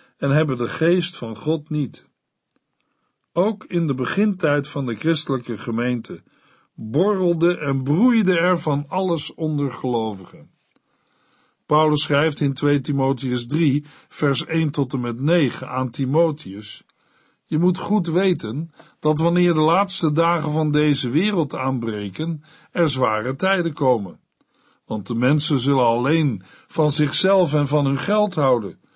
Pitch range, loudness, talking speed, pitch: 135-170 Hz, -20 LUFS, 135 wpm, 150 Hz